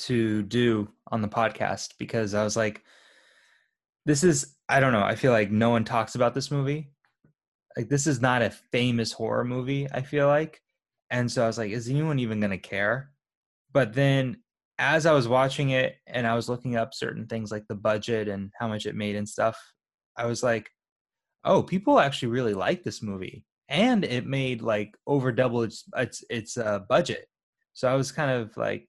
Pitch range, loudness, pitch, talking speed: 110-135 Hz, -26 LUFS, 120 Hz, 200 wpm